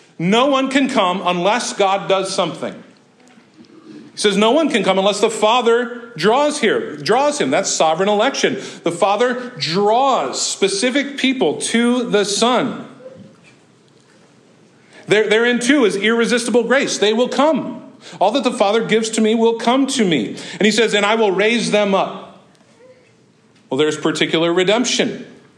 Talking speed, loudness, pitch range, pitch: 155 wpm, -16 LUFS, 205-245 Hz, 225 Hz